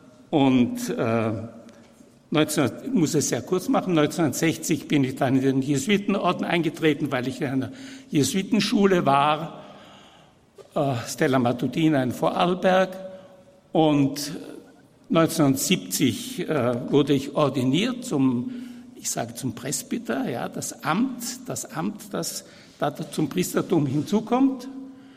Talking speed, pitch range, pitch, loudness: 115 wpm, 135-190 Hz, 155 Hz, -24 LUFS